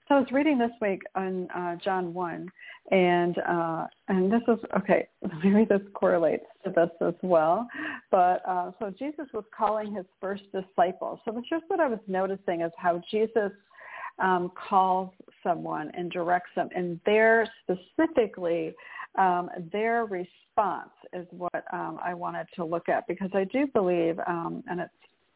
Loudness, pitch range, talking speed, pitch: -28 LUFS, 175-220 Hz, 165 wpm, 190 Hz